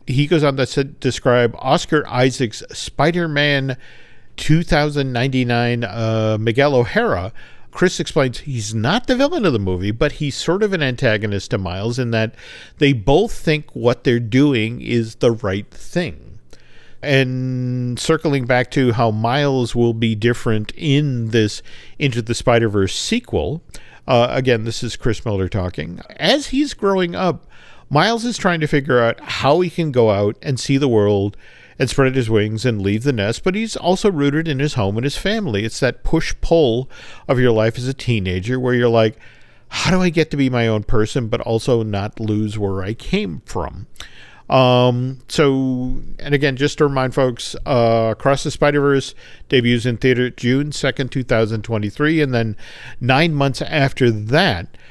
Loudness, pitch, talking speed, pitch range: -18 LUFS, 125 Hz, 170 wpm, 115-145 Hz